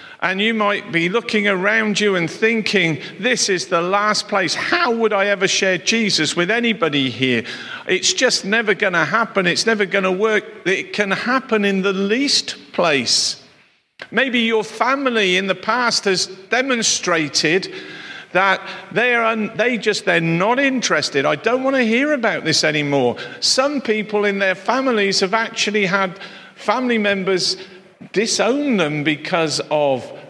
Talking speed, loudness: 165 wpm, -17 LUFS